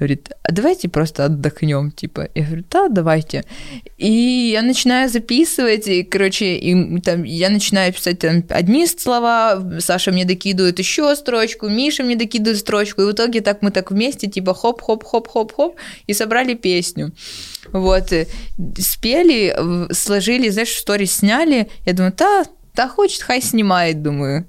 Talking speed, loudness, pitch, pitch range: 155 wpm, -16 LUFS, 205 Hz, 180-235 Hz